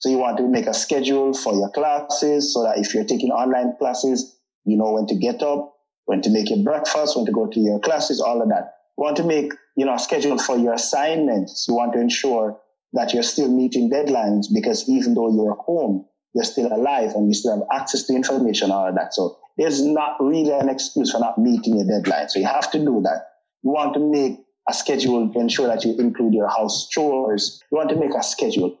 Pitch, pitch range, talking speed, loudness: 130 Hz, 115-150 Hz, 235 wpm, -20 LUFS